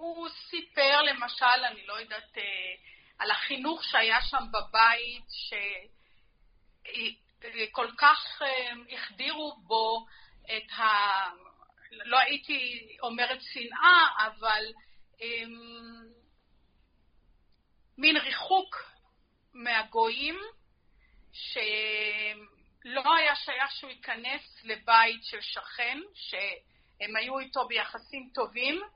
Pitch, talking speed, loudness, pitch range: 240 Hz, 80 wpm, -28 LUFS, 220-280 Hz